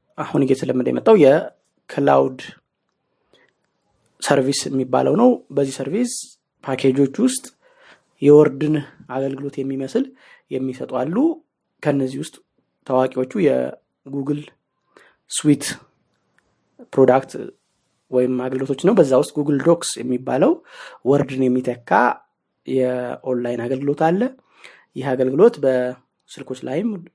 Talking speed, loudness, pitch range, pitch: 85 wpm, -19 LUFS, 130-155 Hz, 140 Hz